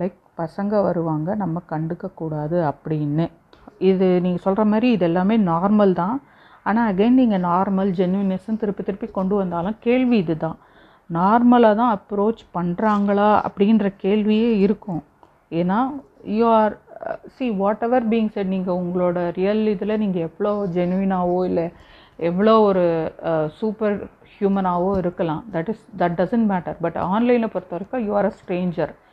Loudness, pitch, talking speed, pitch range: -20 LUFS, 195 Hz, 130 wpm, 175-215 Hz